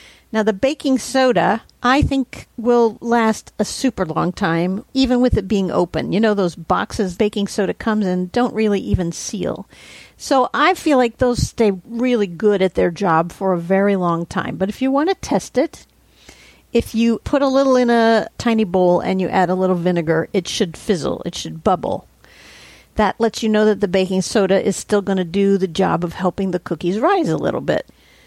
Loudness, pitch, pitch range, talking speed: -18 LUFS, 205 Hz, 185-235 Hz, 205 wpm